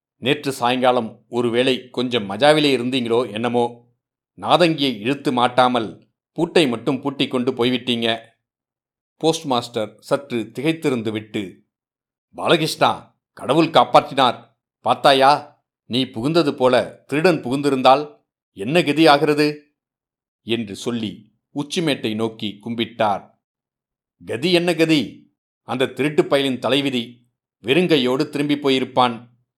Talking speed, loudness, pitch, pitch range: 95 wpm, -19 LUFS, 130 Hz, 120-145 Hz